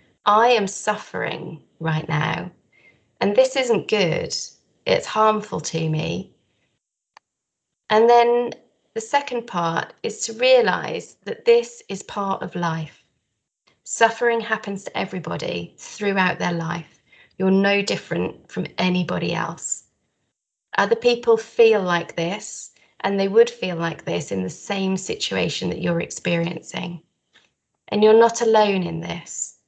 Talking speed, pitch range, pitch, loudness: 130 wpm, 170-230 Hz, 195 Hz, -21 LUFS